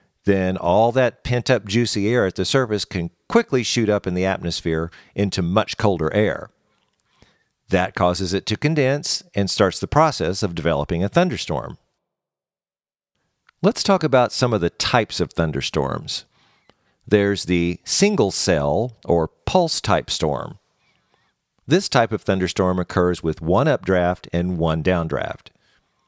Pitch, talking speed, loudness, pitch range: 100 Hz, 145 wpm, -20 LUFS, 90-120 Hz